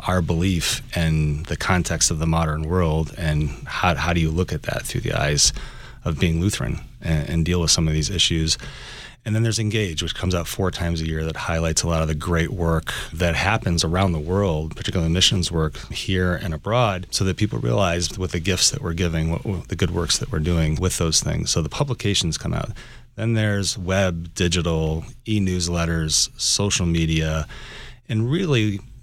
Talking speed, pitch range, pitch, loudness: 200 wpm, 80-100 Hz, 85 Hz, -22 LUFS